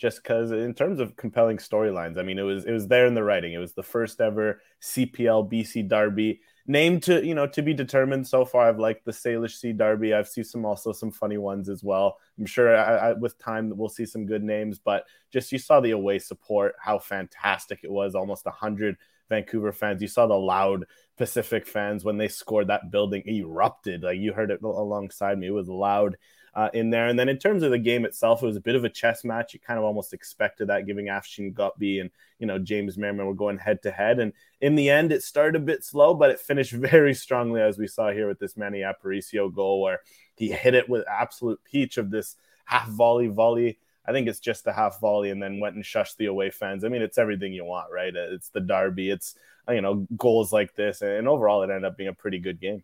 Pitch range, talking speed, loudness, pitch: 100-115 Hz, 240 wpm, -25 LUFS, 110 Hz